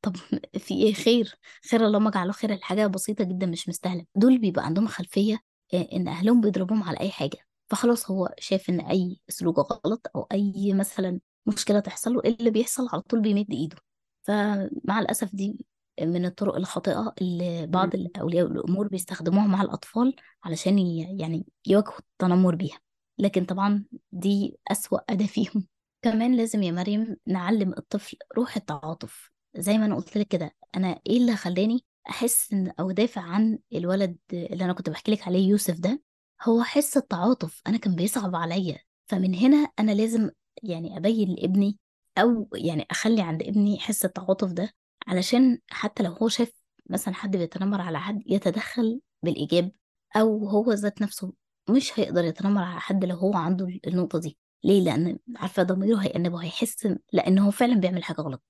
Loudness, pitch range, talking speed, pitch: -26 LUFS, 180-220 Hz, 160 wpm, 195 Hz